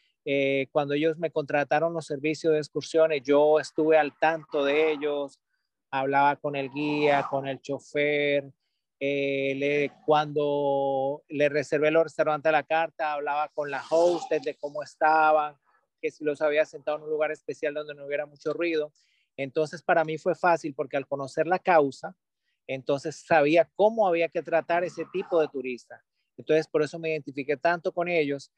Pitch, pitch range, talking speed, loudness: 150 Hz, 145-160 Hz, 170 wpm, -26 LUFS